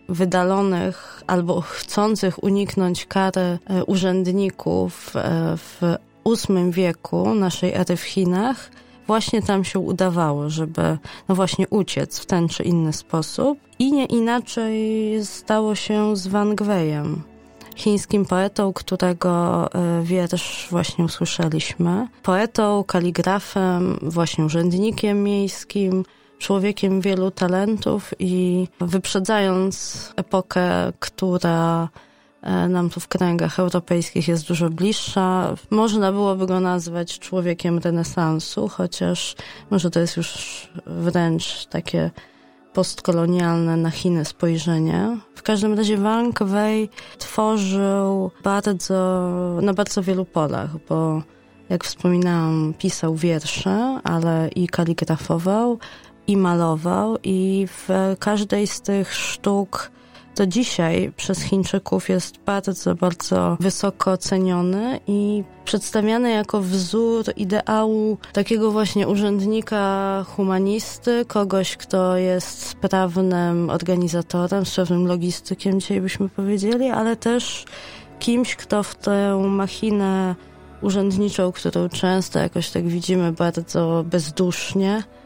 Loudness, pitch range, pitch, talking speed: -21 LUFS, 175-205 Hz, 185 Hz, 105 wpm